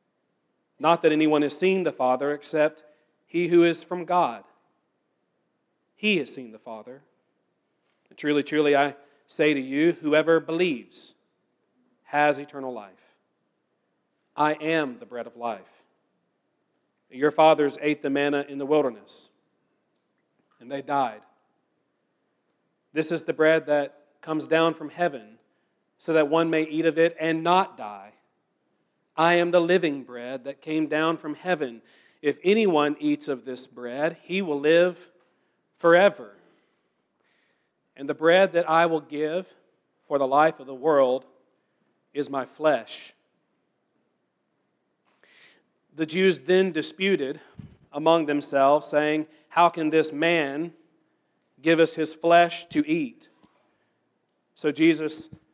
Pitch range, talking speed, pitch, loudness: 145-165 Hz, 130 wpm, 155 Hz, -24 LUFS